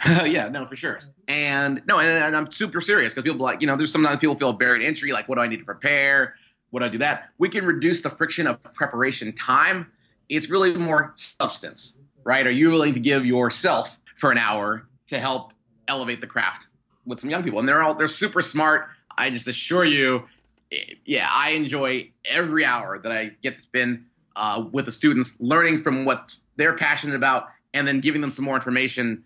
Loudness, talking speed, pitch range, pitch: -22 LUFS, 215 wpm, 125-155 Hz, 140 Hz